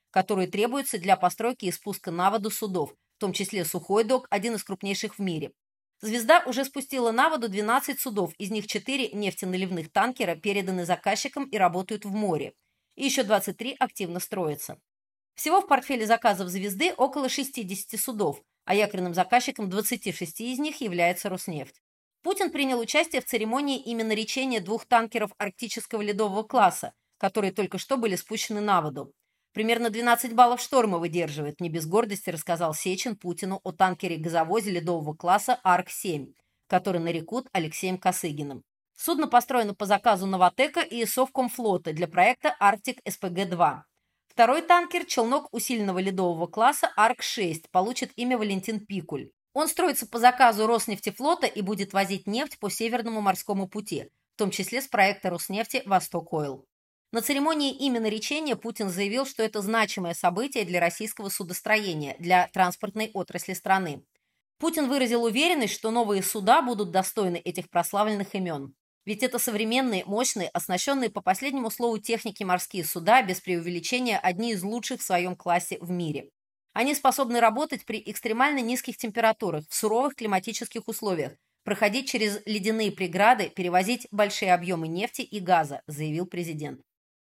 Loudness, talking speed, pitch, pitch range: -26 LUFS, 145 wpm, 210 Hz, 185-240 Hz